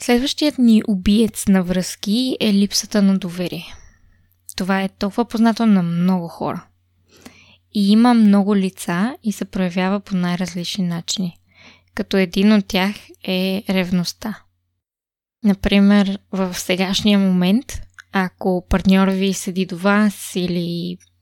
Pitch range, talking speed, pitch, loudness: 180-210 Hz, 120 wpm, 190 Hz, -18 LUFS